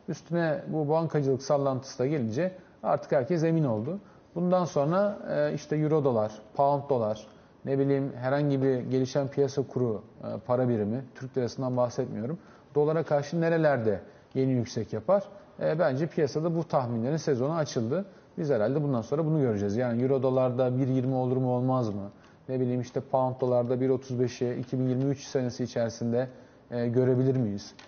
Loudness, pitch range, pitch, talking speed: -28 LUFS, 125-150 Hz, 130 Hz, 140 wpm